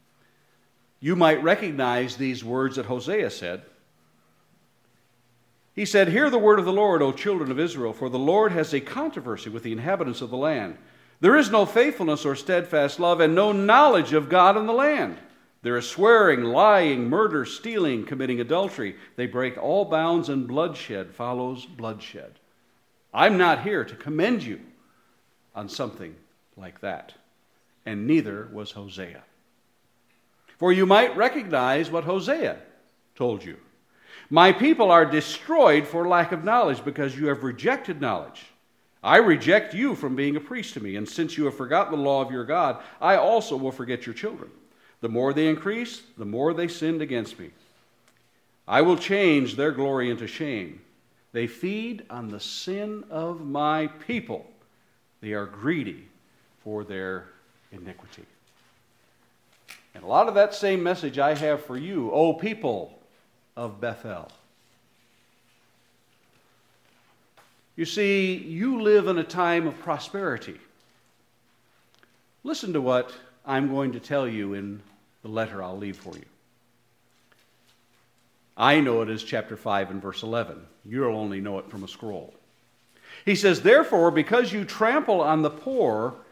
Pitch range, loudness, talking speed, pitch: 120-180 Hz, -23 LUFS, 150 wpm, 140 Hz